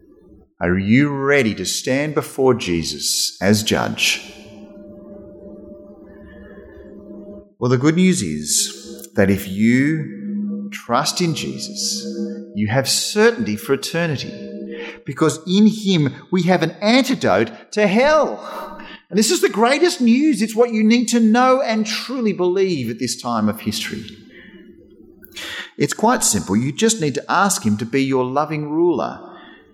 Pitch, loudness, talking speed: 150 Hz, -18 LUFS, 135 wpm